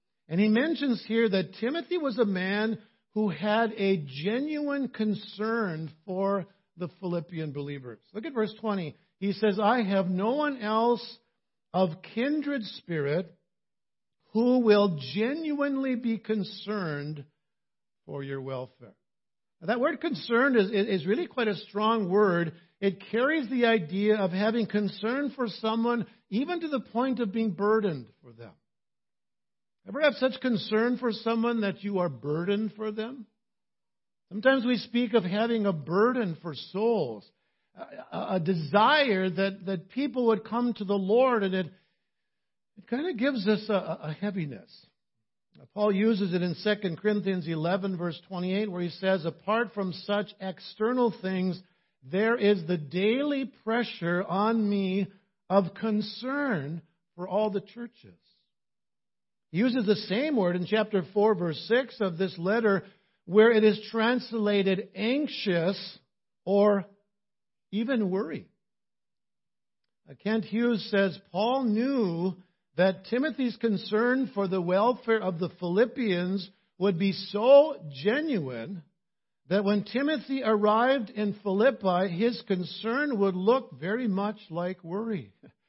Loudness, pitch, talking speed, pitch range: -28 LUFS, 205 Hz, 135 wpm, 185-230 Hz